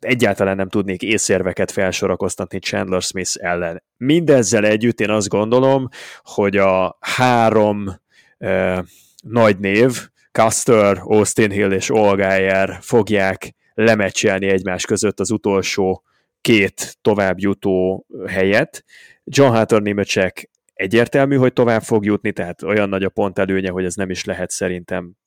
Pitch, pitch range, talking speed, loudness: 100 Hz, 95-110 Hz, 125 wpm, -17 LUFS